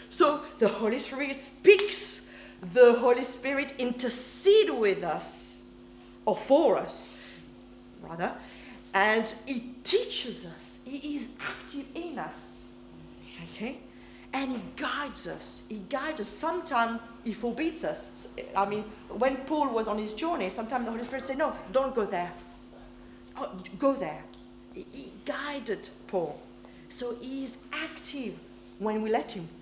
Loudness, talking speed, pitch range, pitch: -28 LUFS, 140 wpm, 175-275 Hz, 235 Hz